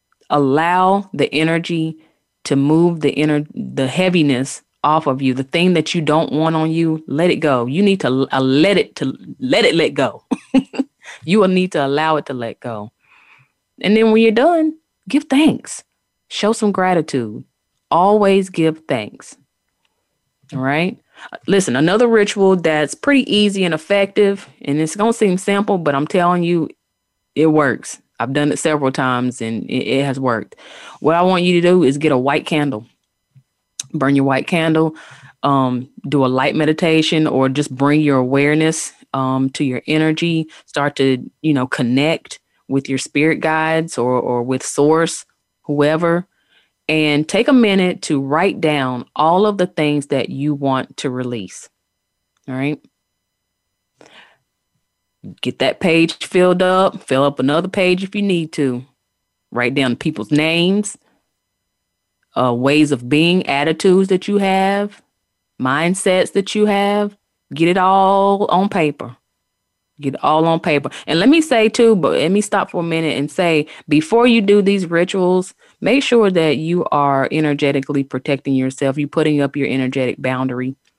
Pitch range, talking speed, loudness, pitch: 135-185 Hz, 160 wpm, -16 LUFS, 155 Hz